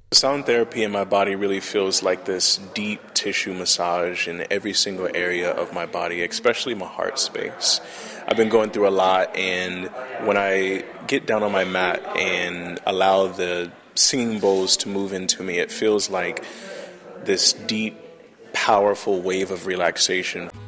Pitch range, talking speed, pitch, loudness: 90-100 Hz, 165 wpm, 95 Hz, -21 LUFS